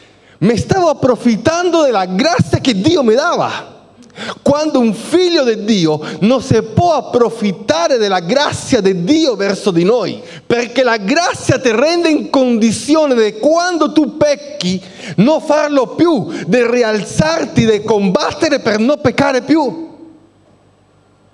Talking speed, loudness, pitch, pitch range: 130 wpm, -13 LUFS, 250 Hz, 210-300 Hz